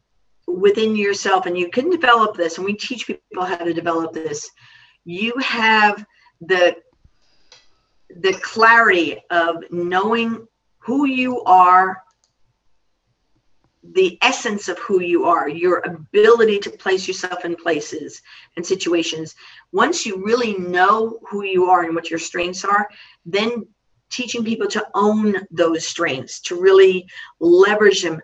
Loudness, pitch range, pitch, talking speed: -17 LUFS, 175-230 Hz, 200 Hz, 135 wpm